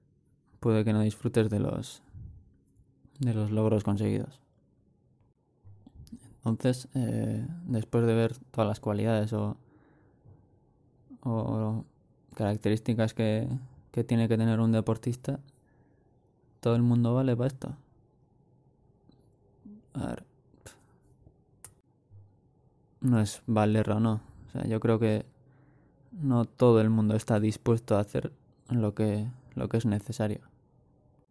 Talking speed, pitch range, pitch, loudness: 115 wpm, 110-130 Hz, 115 Hz, -29 LUFS